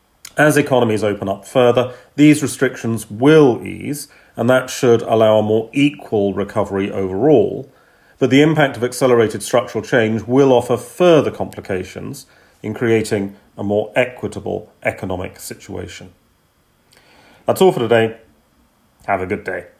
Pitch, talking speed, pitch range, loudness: 115 Hz, 135 wpm, 100-130 Hz, -16 LUFS